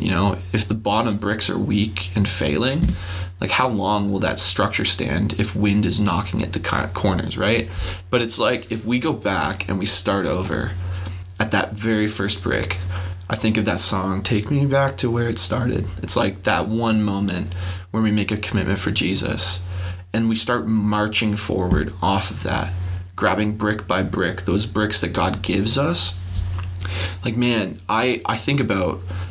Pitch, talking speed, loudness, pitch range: 100 Hz, 180 wpm, -21 LUFS, 90-110 Hz